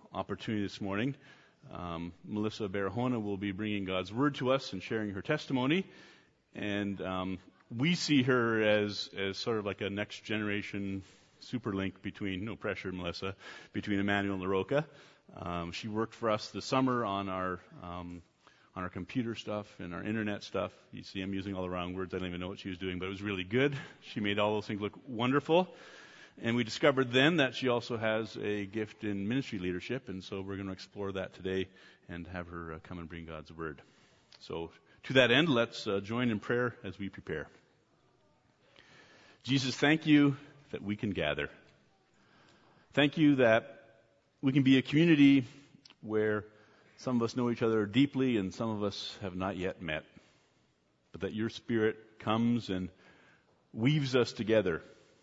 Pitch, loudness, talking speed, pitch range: 105 Hz, -33 LUFS, 180 wpm, 95-125 Hz